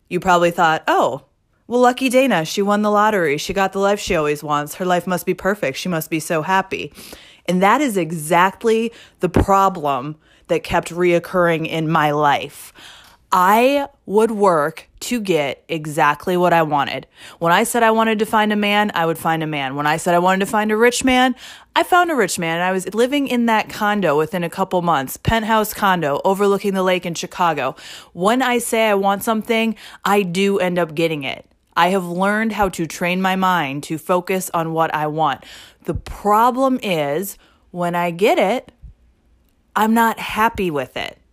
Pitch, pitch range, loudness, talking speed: 185 Hz, 165-215 Hz, -18 LUFS, 195 wpm